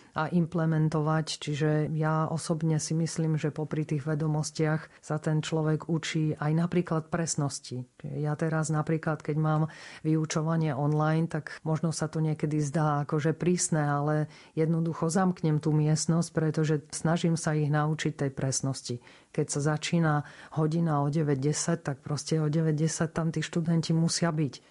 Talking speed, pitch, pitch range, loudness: 145 wpm, 155 Hz, 150-160 Hz, -29 LUFS